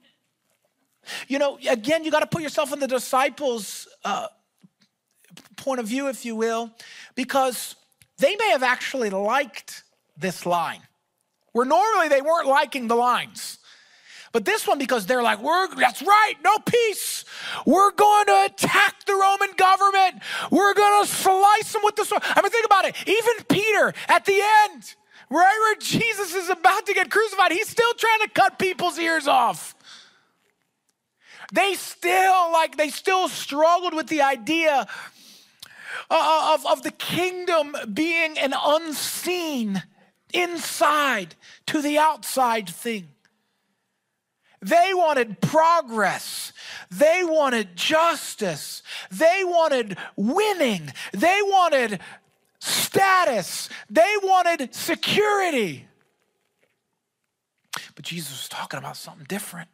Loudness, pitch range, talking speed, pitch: -21 LUFS, 250-380 Hz, 130 wpm, 320 Hz